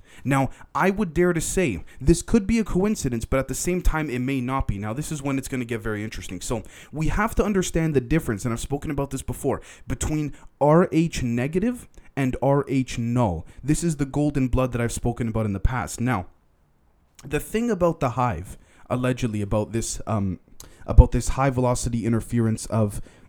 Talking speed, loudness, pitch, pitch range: 200 wpm, -24 LUFS, 130 Hz, 115-150 Hz